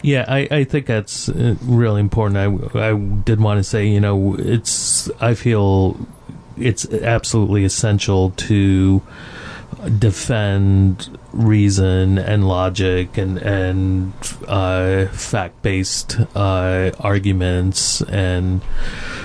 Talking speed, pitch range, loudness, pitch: 105 wpm, 95-115 Hz, -17 LUFS, 100 Hz